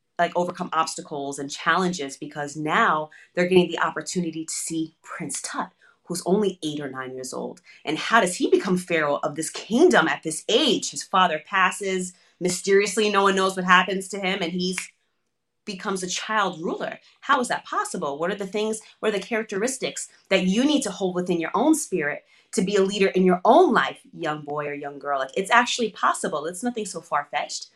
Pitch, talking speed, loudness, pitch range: 180 Hz, 205 wpm, -23 LUFS, 160-205 Hz